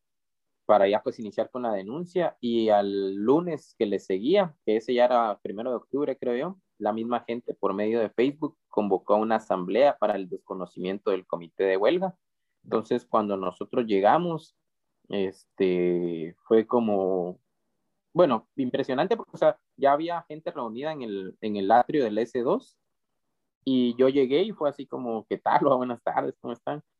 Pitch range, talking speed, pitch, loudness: 100-140 Hz, 170 wpm, 120 Hz, -26 LUFS